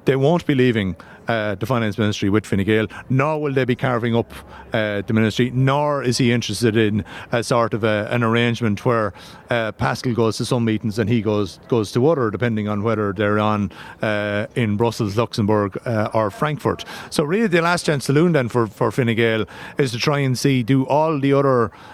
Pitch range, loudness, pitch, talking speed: 105-130 Hz, -20 LUFS, 115 Hz, 205 wpm